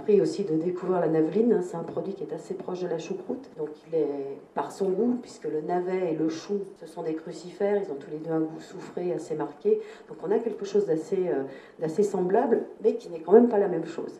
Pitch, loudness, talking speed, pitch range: 180 Hz, -28 LUFS, 250 wpm, 160-205 Hz